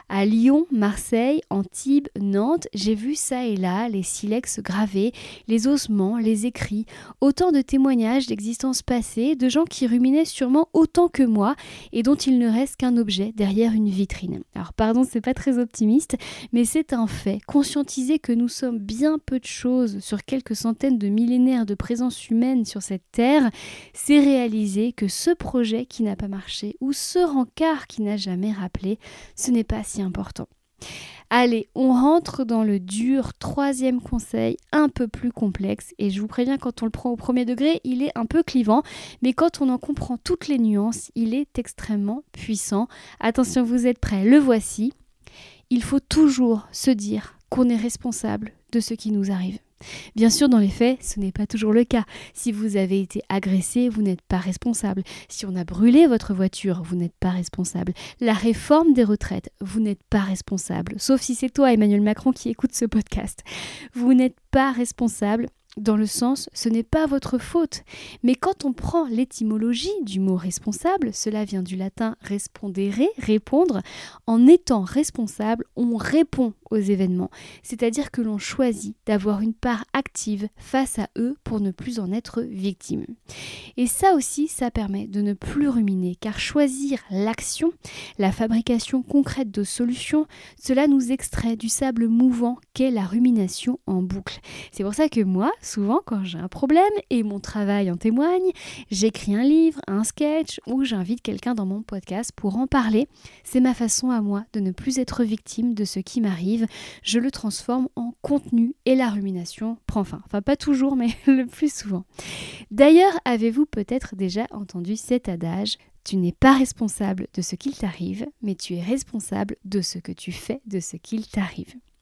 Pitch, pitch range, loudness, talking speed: 230 Hz, 205-260 Hz, -22 LUFS, 180 wpm